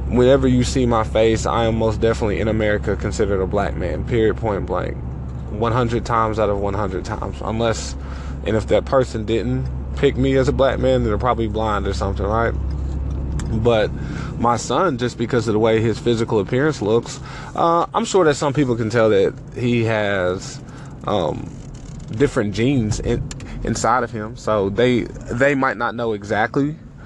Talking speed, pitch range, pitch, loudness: 180 wpm, 105-130 Hz, 115 Hz, -20 LUFS